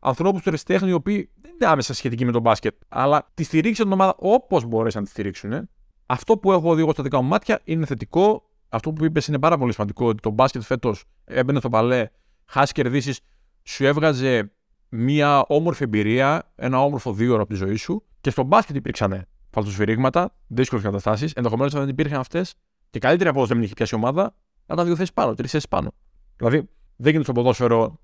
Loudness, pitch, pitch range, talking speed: -21 LUFS, 135 Hz, 115-160 Hz, 195 wpm